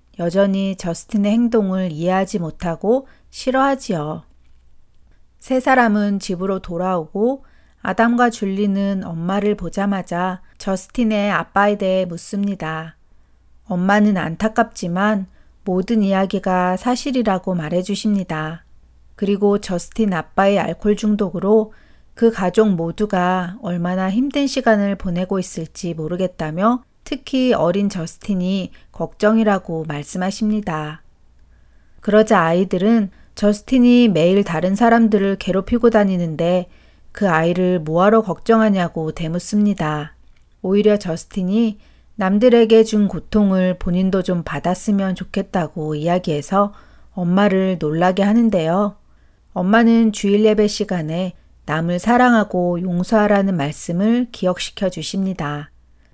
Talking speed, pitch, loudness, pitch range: 280 characters per minute, 190 Hz, -18 LUFS, 175-210 Hz